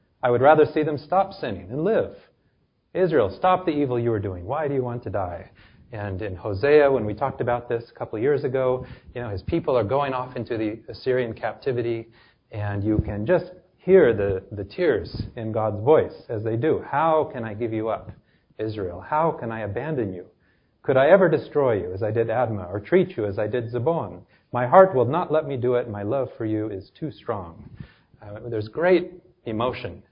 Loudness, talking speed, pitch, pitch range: -23 LUFS, 215 wpm, 120 Hz, 105-140 Hz